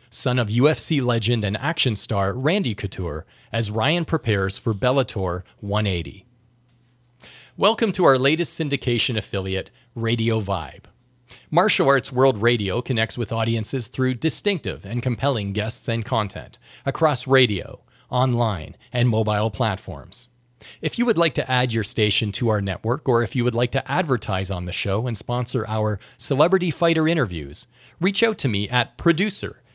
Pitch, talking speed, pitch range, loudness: 120 Hz, 155 wpm, 105-135 Hz, -21 LUFS